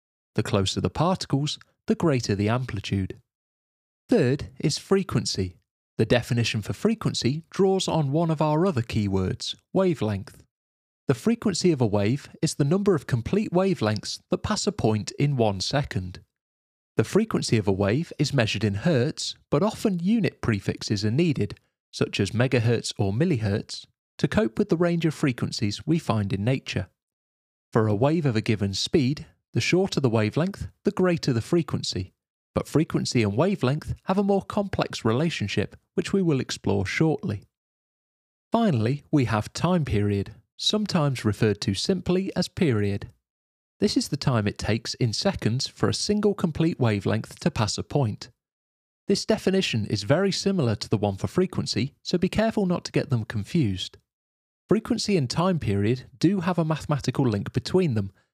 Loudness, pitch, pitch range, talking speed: -25 LUFS, 125 Hz, 105-175 Hz, 165 wpm